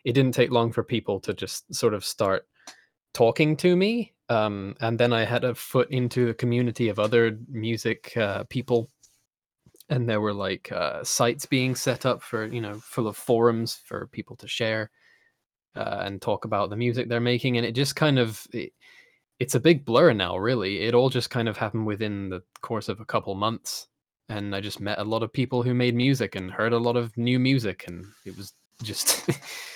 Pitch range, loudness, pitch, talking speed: 110-125 Hz, -25 LUFS, 120 Hz, 210 wpm